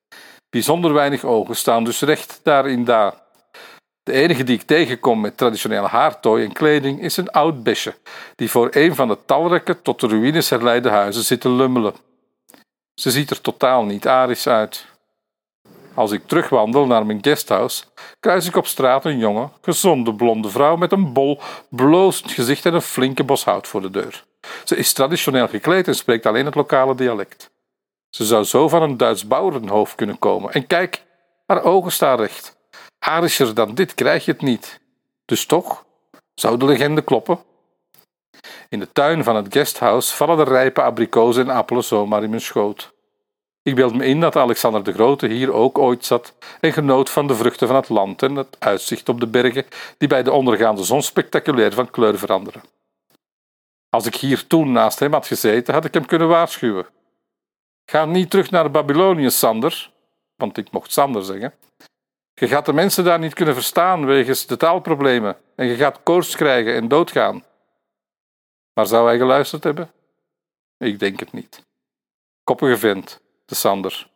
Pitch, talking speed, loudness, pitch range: 135 Hz, 175 wpm, -17 LUFS, 120-160 Hz